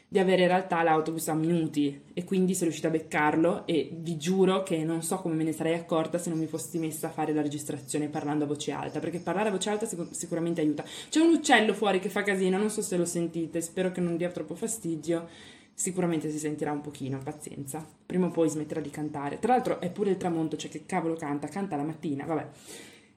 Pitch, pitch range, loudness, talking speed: 165 Hz, 155-185 Hz, -29 LUFS, 230 wpm